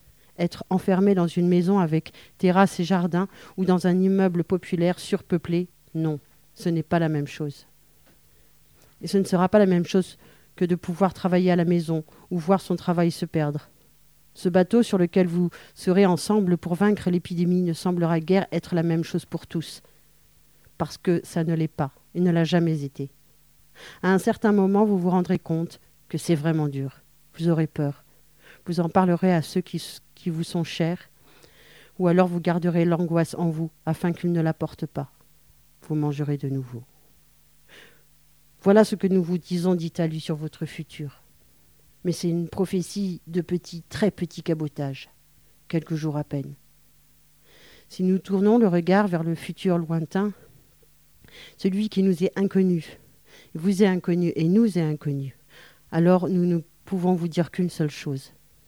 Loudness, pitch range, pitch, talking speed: -24 LUFS, 160-185 Hz, 175 Hz, 175 wpm